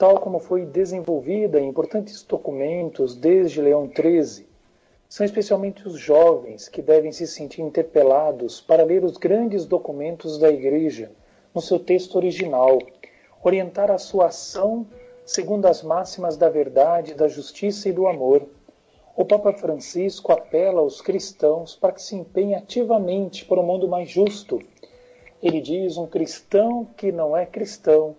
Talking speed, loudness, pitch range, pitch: 145 wpm, -21 LUFS, 155-200 Hz, 180 Hz